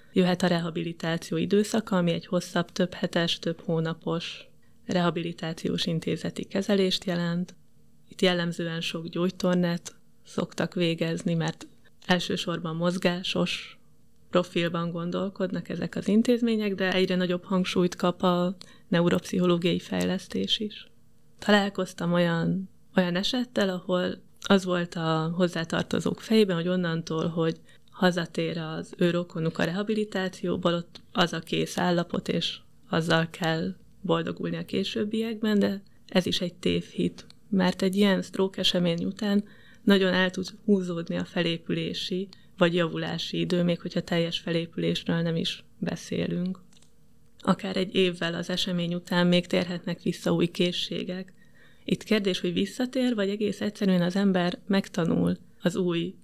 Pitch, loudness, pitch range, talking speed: 180 Hz, -27 LUFS, 170-190 Hz, 125 wpm